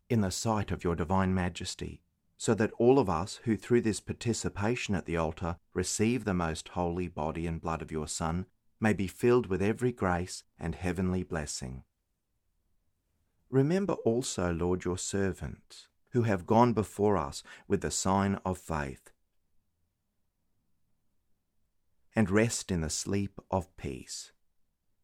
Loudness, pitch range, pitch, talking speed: -31 LUFS, 85-105 Hz, 95 Hz, 145 wpm